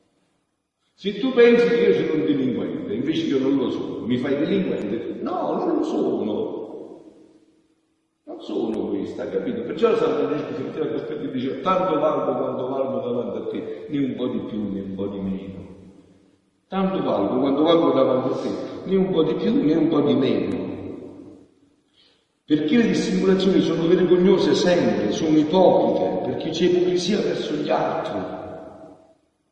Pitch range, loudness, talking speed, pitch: 130-200 Hz, -22 LUFS, 165 wpm, 175 Hz